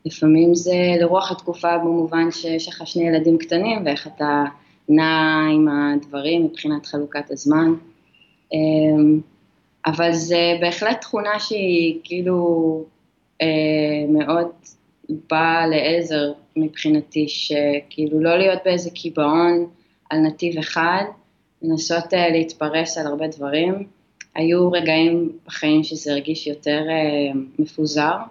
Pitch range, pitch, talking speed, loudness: 155-170 Hz, 160 Hz, 100 wpm, -19 LUFS